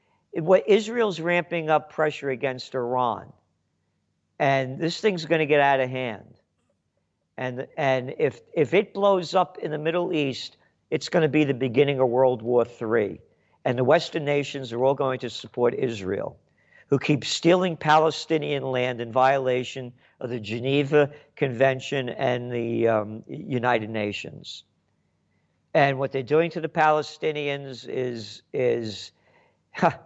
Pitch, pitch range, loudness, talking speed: 135 Hz, 125-155 Hz, -24 LUFS, 145 wpm